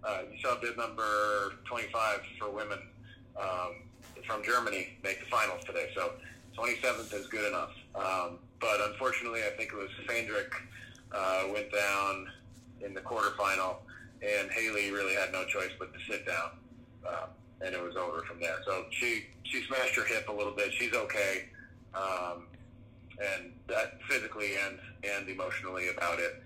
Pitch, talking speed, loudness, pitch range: 105 Hz, 160 wpm, -34 LUFS, 95-115 Hz